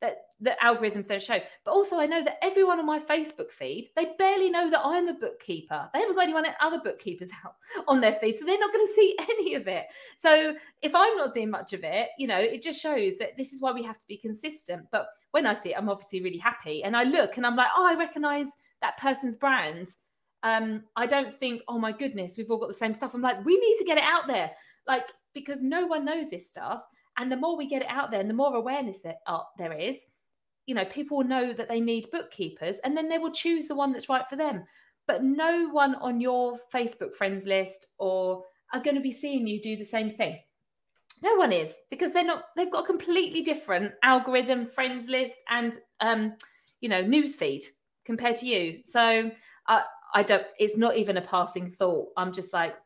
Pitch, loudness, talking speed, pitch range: 260 Hz, -27 LUFS, 230 wpm, 220-315 Hz